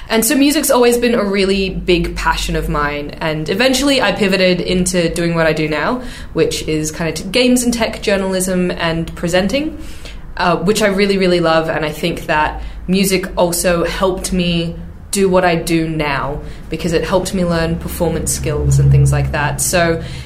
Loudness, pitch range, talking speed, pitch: -15 LUFS, 160-195 Hz, 185 wpm, 175 Hz